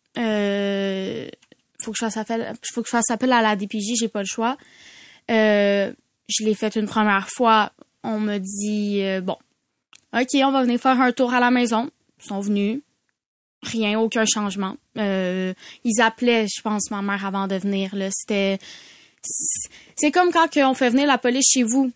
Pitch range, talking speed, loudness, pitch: 200-245 Hz, 185 wpm, -21 LUFS, 220 Hz